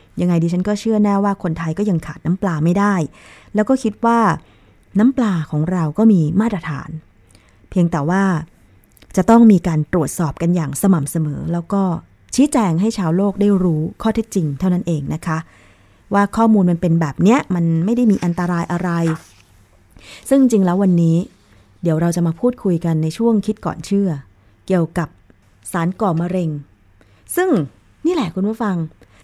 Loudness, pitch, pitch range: -17 LUFS, 175 Hz, 155-200 Hz